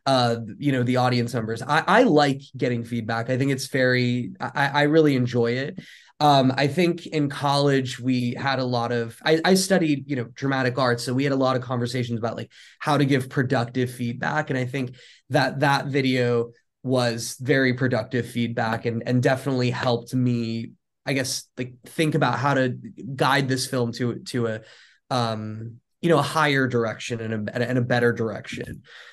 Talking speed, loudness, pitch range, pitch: 185 wpm, -23 LUFS, 120-140 Hz, 125 Hz